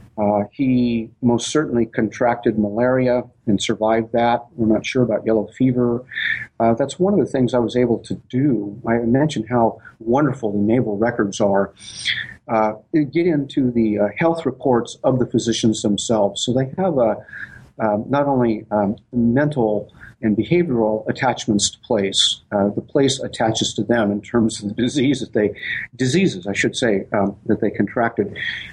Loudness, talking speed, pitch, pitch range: -19 LUFS, 175 wpm, 115 Hz, 105-125 Hz